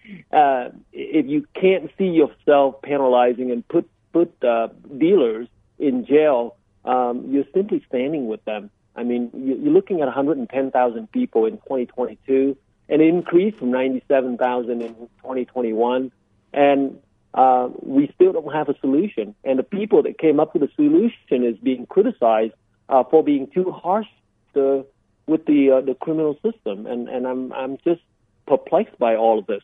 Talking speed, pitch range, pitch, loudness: 155 wpm, 120-170 Hz, 135 Hz, -20 LUFS